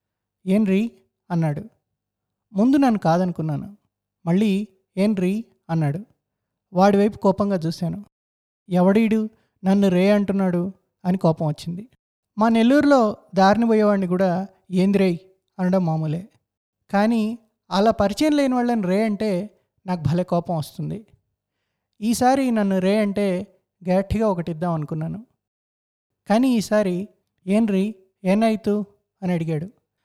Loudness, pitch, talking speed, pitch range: -21 LUFS, 195 Hz, 105 wpm, 180-215 Hz